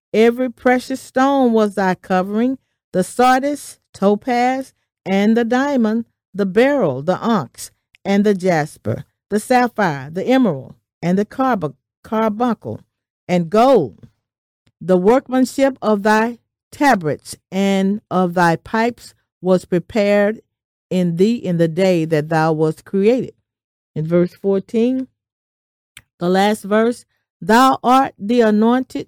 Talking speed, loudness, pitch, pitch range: 120 wpm, -17 LUFS, 205 Hz, 180-240 Hz